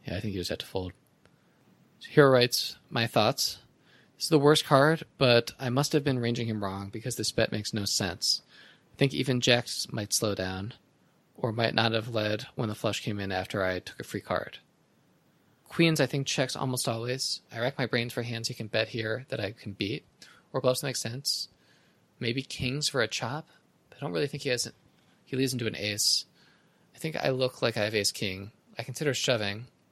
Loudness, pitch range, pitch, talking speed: -28 LUFS, 110-135 Hz, 120 Hz, 220 wpm